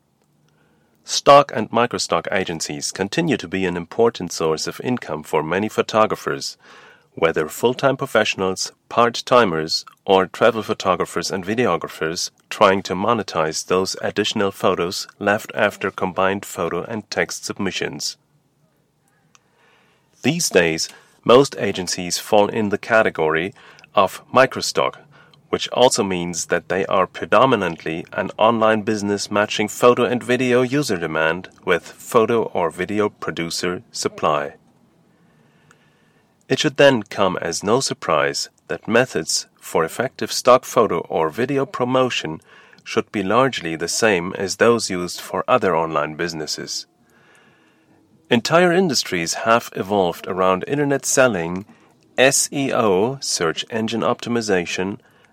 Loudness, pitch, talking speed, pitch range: -19 LUFS, 105 Hz, 120 wpm, 90-125 Hz